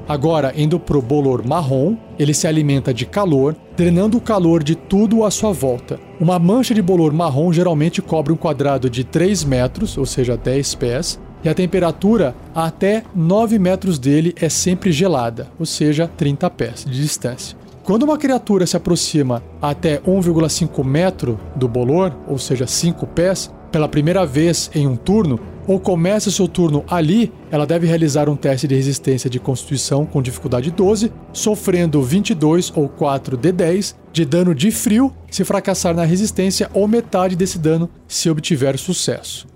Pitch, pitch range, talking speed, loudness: 165 Hz, 145-190 Hz, 165 wpm, -17 LUFS